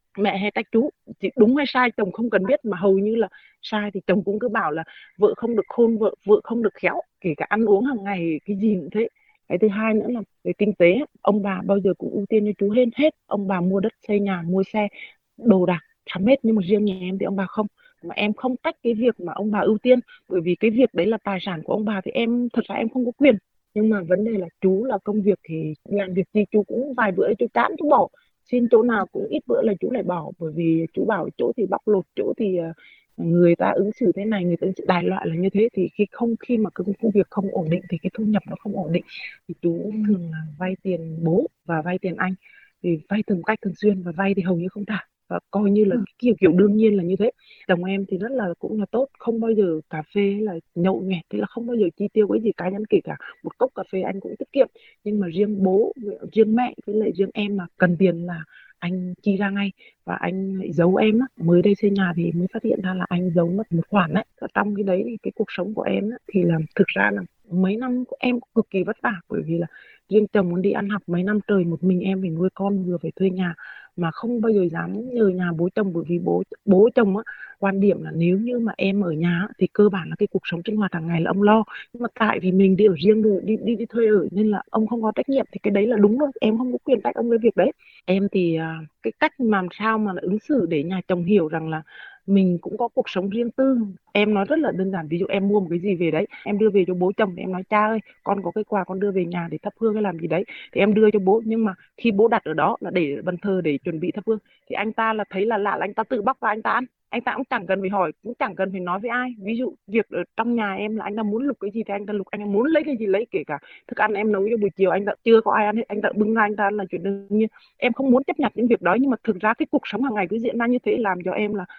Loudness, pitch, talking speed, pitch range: -22 LUFS, 205 Hz, 300 wpm, 185-225 Hz